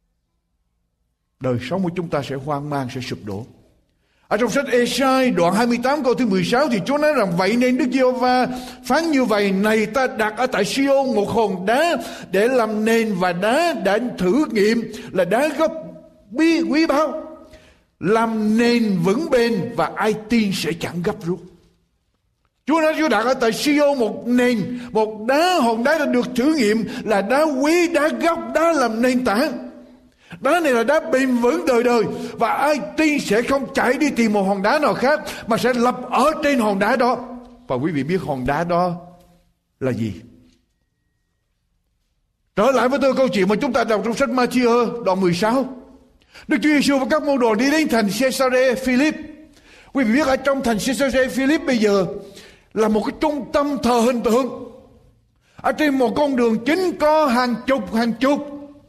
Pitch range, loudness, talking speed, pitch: 205-275 Hz, -19 LUFS, 190 wpm, 245 Hz